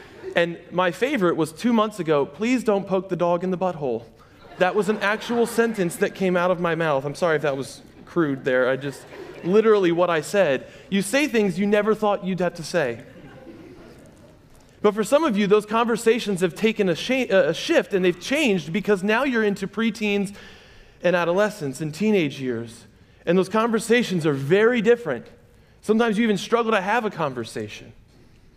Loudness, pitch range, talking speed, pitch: -22 LUFS, 165-220 Hz, 185 wpm, 190 Hz